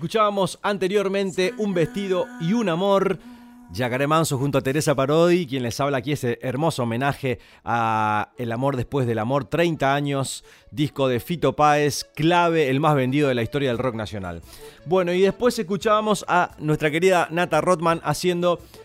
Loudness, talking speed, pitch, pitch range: -22 LUFS, 165 wpm, 150 Hz, 130-180 Hz